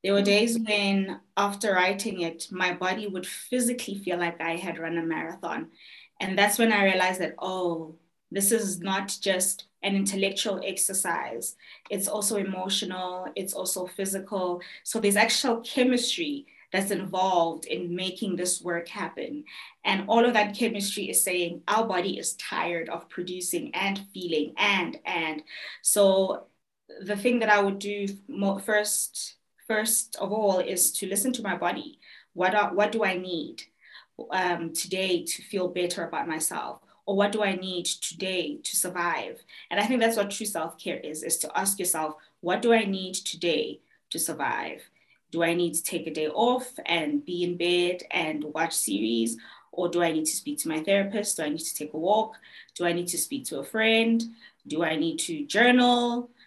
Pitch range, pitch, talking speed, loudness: 175-215 Hz, 195 Hz, 175 wpm, -27 LUFS